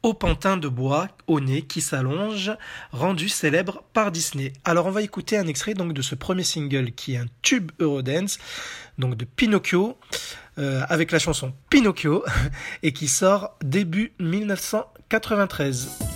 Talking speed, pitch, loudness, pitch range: 150 wpm, 170 Hz, -24 LUFS, 145-205 Hz